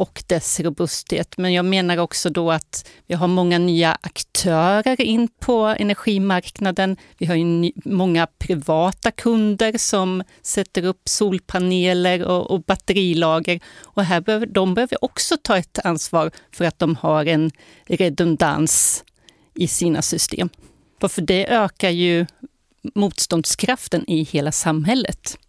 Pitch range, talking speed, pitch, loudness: 170-200 Hz, 130 wpm, 180 Hz, -19 LUFS